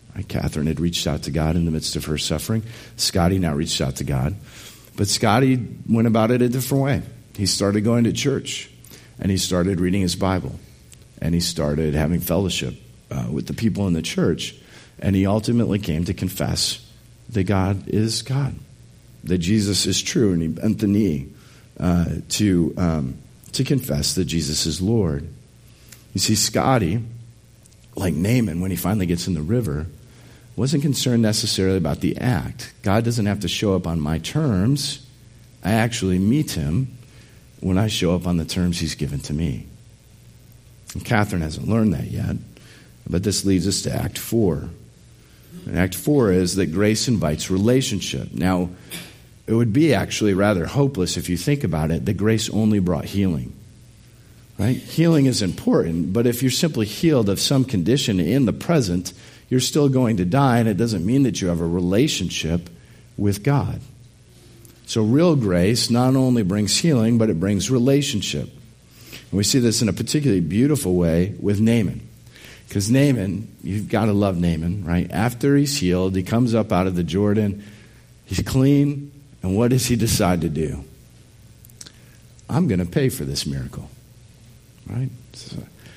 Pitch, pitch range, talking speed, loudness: 105 Hz, 90-120 Hz, 170 wpm, -21 LUFS